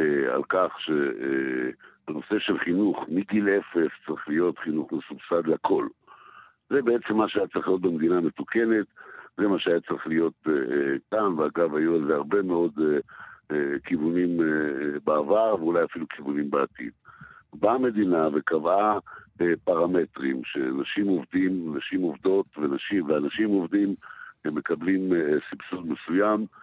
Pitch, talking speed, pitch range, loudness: 90 Hz, 120 wpm, 75-100 Hz, -26 LUFS